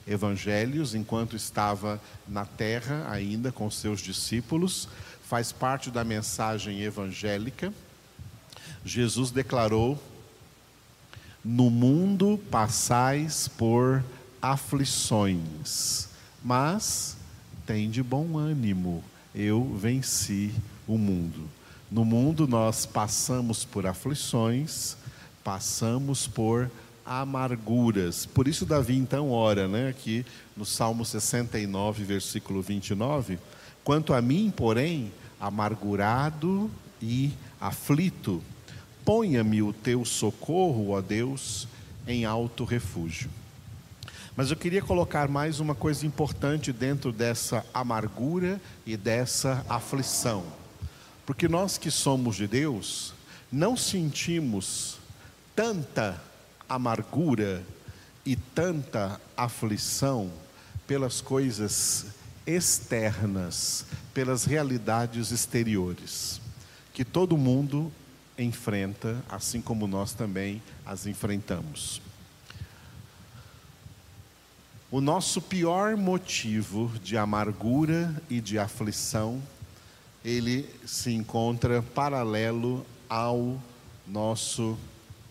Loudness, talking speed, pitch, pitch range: -28 LUFS, 90 wpm, 120 Hz, 105-135 Hz